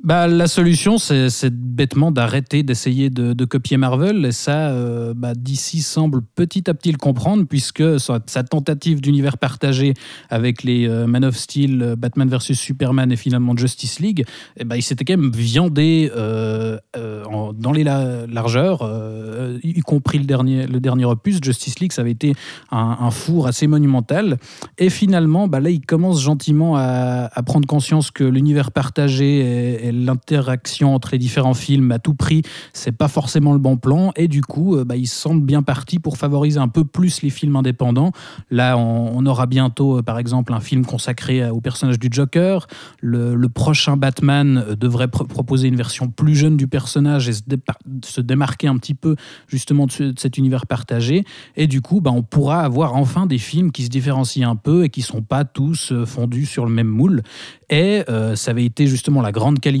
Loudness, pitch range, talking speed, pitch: -17 LUFS, 125-150 Hz, 195 wpm, 135 Hz